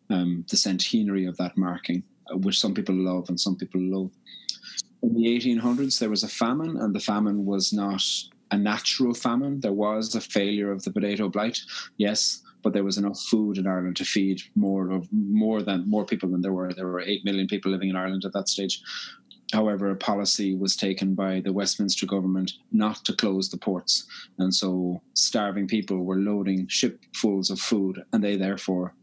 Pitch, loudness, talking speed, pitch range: 95 Hz, -26 LUFS, 190 wpm, 95-105 Hz